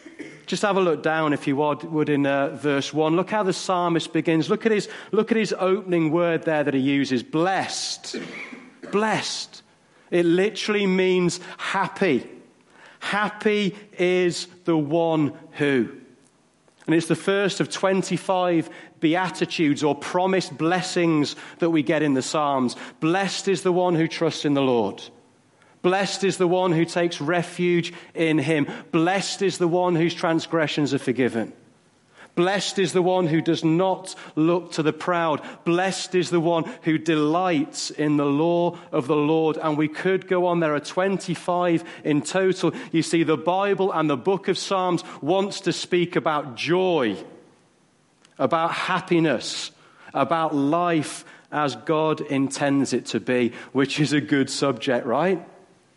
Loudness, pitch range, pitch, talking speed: -23 LUFS, 155-185 Hz, 170 Hz, 155 wpm